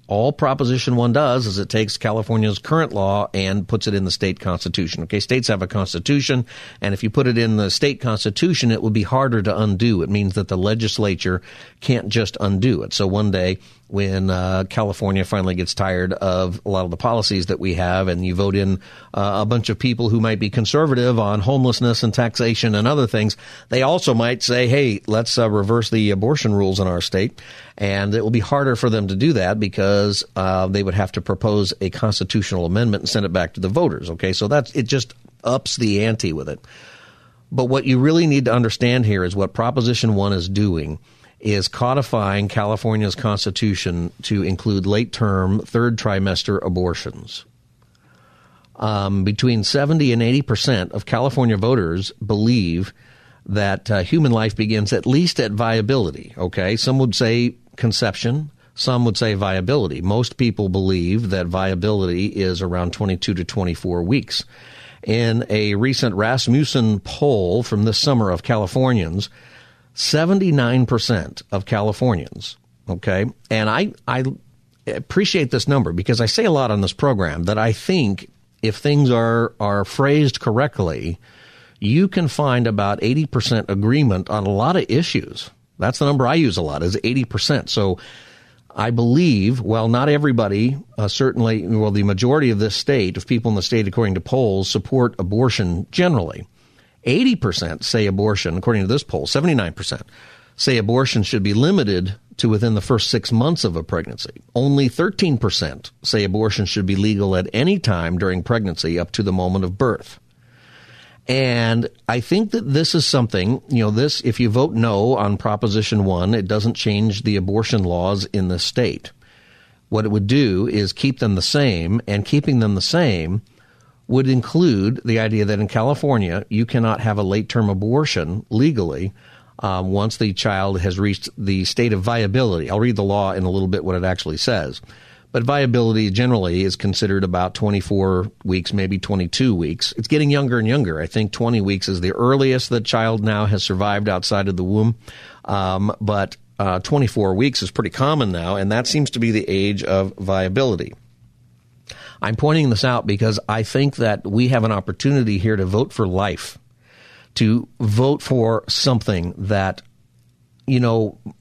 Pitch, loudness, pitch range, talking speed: 110 Hz, -19 LUFS, 100-125 Hz, 180 wpm